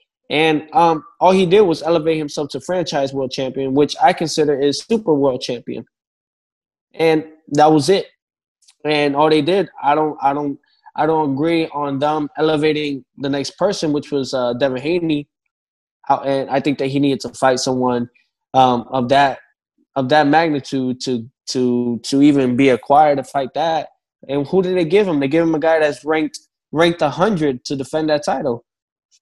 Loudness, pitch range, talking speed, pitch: -17 LUFS, 135-160 Hz, 180 wpm, 145 Hz